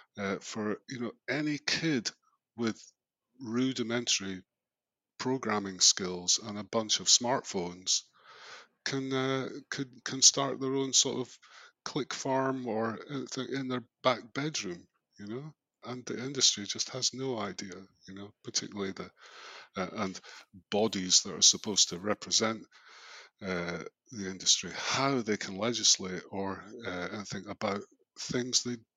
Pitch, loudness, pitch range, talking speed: 120 Hz, -30 LUFS, 95-130 Hz, 140 wpm